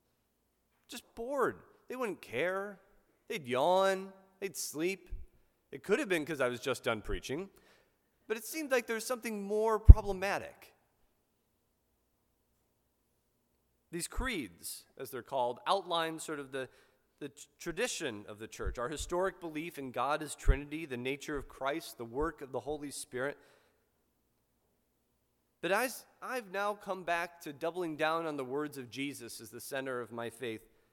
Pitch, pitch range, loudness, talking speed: 160 Hz, 135-195 Hz, -35 LUFS, 150 wpm